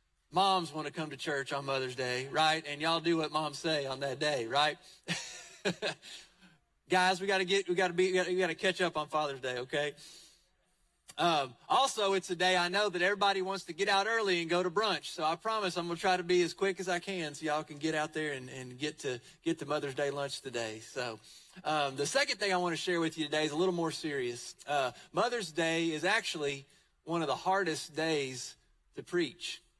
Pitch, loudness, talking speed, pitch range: 165 Hz, -32 LUFS, 230 wpm, 145-185 Hz